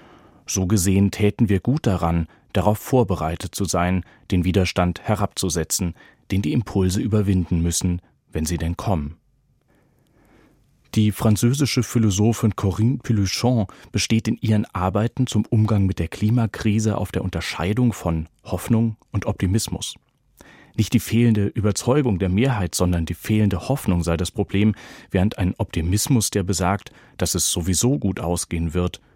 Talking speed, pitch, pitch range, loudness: 140 wpm, 100 Hz, 90-110 Hz, -21 LUFS